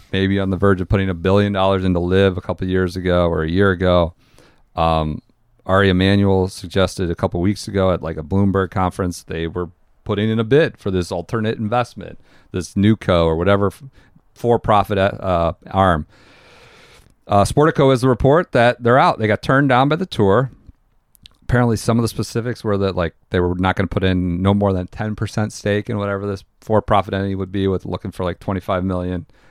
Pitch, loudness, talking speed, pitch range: 95 Hz, -18 LUFS, 205 wpm, 90-110 Hz